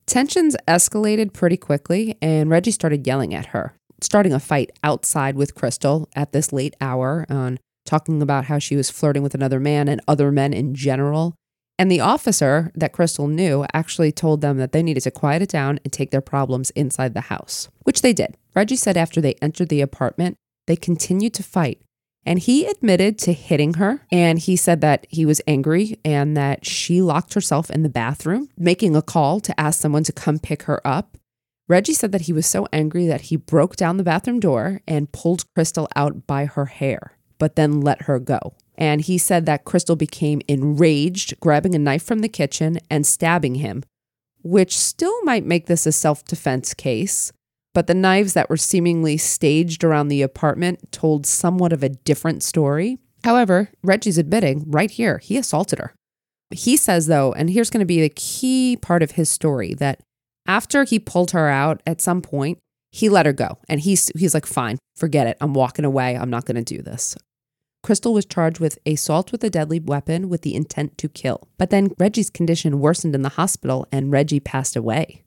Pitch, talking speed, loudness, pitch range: 155 Hz, 195 wpm, -19 LUFS, 140-180 Hz